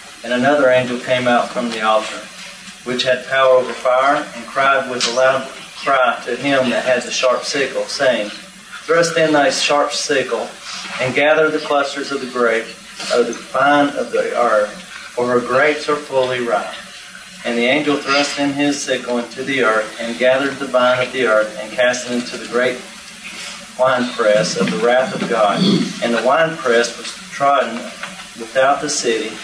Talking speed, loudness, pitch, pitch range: 180 wpm, -16 LUFS, 125 Hz, 120-140 Hz